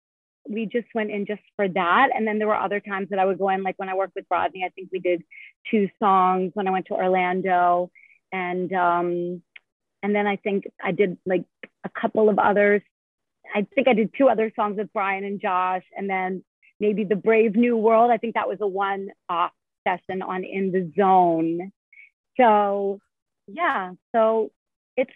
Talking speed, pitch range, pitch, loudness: 195 wpm, 185-215 Hz, 195 Hz, -23 LUFS